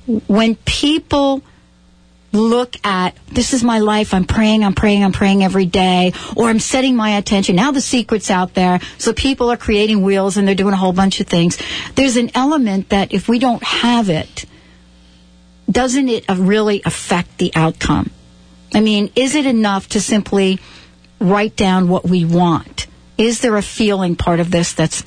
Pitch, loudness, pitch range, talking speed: 200 Hz, -15 LUFS, 180-230 Hz, 175 wpm